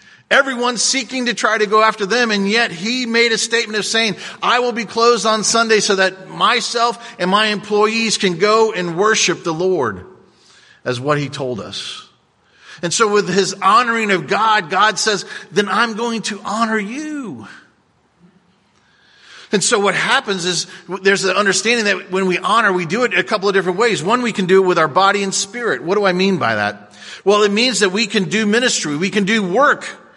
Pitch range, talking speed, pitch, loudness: 190-230 Hz, 205 wpm, 210 Hz, -15 LUFS